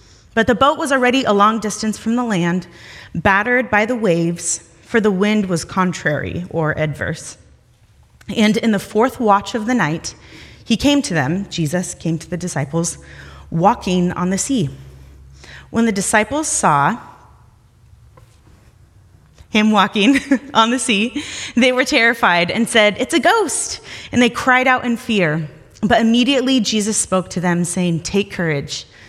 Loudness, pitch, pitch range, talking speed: -17 LUFS, 200 Hz, 160-235 Hz, 155 wpm